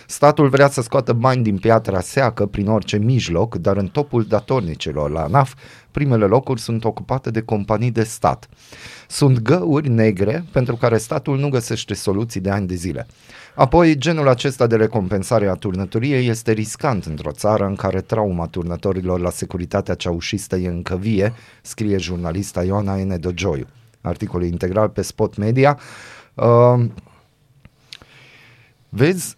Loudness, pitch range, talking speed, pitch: -19 LUFS, 95-125 Hz, 145 wpm, 110 Hz